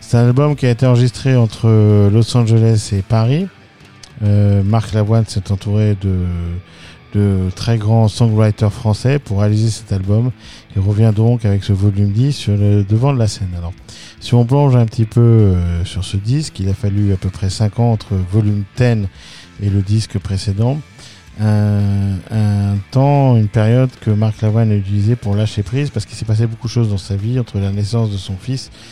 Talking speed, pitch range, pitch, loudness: 195 wpm, 100-115 Hz, 105 Hz, -15 LUFS